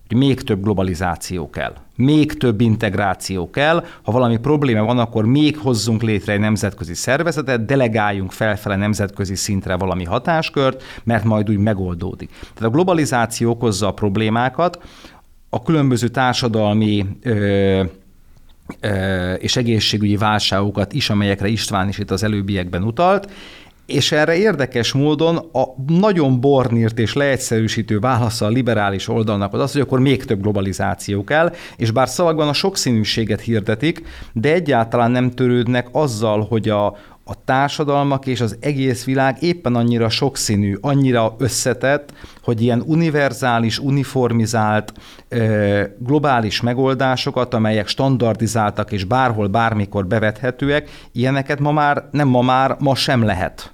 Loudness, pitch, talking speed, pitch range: -18 LUFS, 115 Hz, 135 wpm, 105-135 Hz